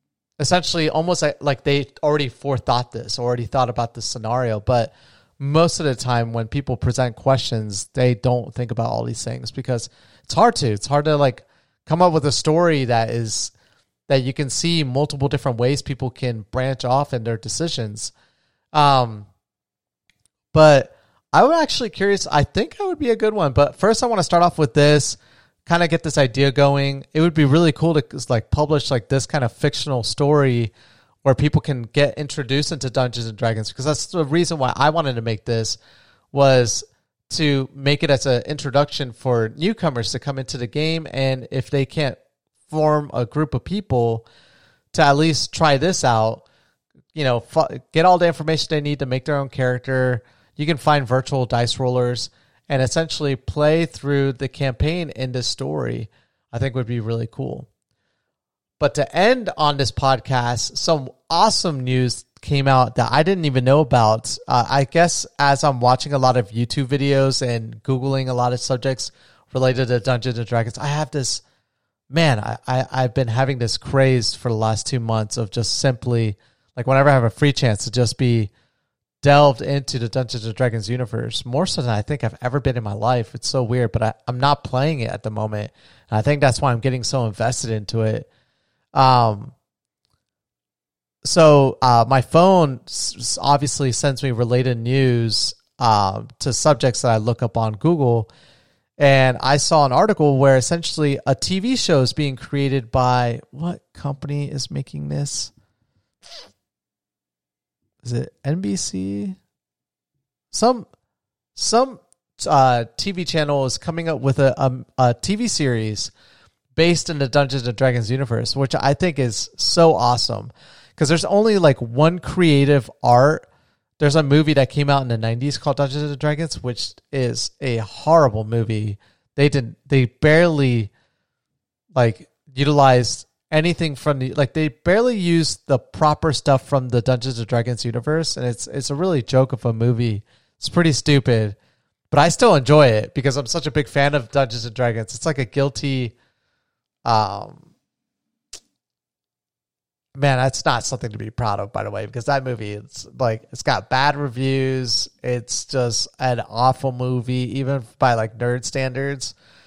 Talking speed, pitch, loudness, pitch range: 175 wpm, 130 Hz, -19 LUFS, 120-145 Hz